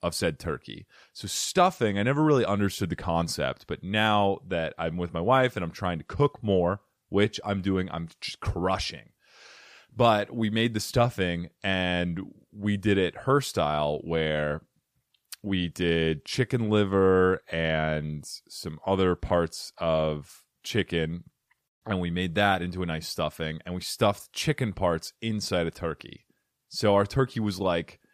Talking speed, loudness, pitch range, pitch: 155 wpm, -27 LUFS, 85-105 Hz, 95 Hz